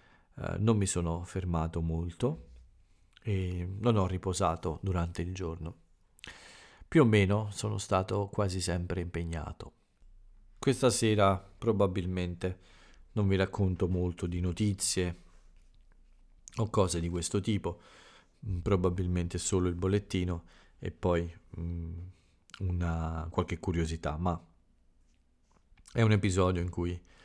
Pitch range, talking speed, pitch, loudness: 85-100 Hz, 110 wpm, 90 Hz, -32 LUFS